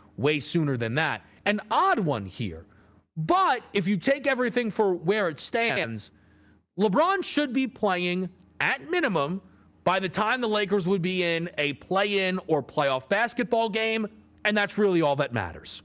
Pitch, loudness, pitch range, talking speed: 185 Hz, -26 LUFS, 145-215 Hz, 165 wpm